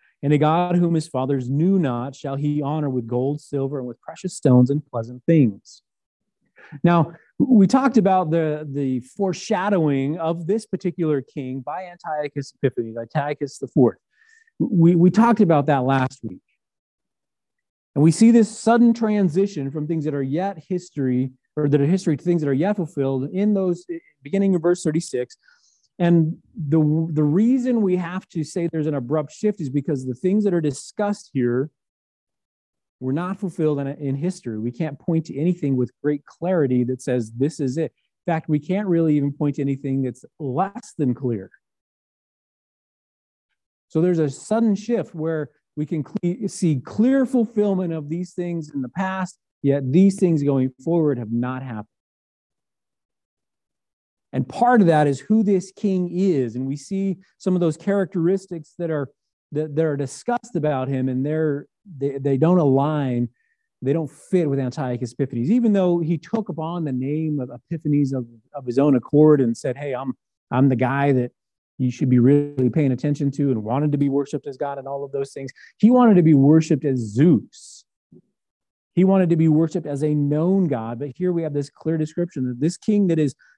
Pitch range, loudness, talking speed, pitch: 135-180 Hz, -21 LUFS, 185 wpm, 155 Hz